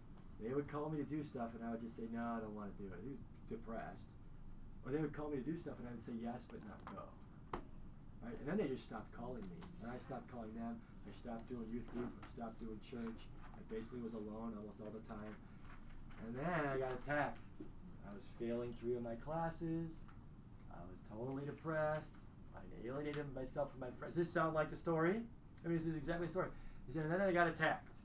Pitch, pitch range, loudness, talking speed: 125 Hz, 115-150 Hz, -45 LUFS, 230 wpm